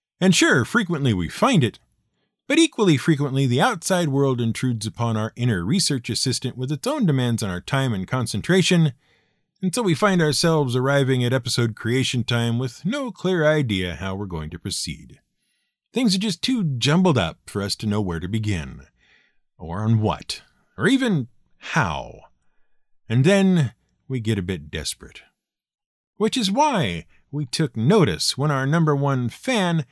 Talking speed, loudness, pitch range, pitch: 165 wpm, -21 LUFS, 115-185 Hz, 140 Hz